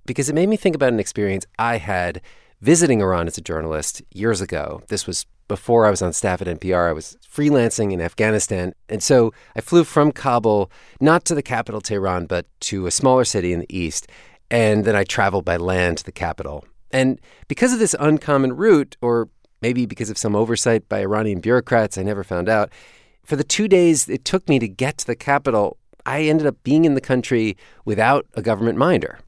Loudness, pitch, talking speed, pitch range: -19 LUFS, 115 Hz, 205 wpm, 100-140 Hz